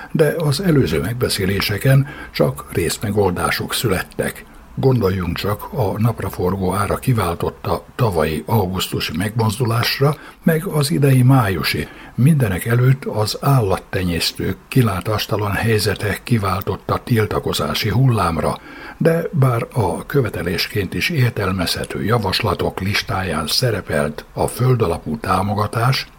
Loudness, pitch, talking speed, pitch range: -18 LUFS, 115 Hz, 95 wpm, 95-135 Hz